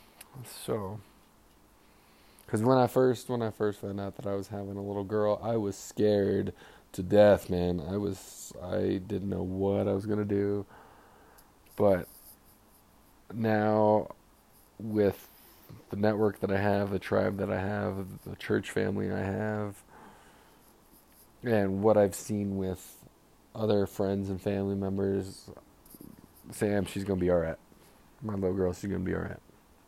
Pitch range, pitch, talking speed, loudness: 95-105 Hz, 100 Hz, 155 wpm, -30 LUFS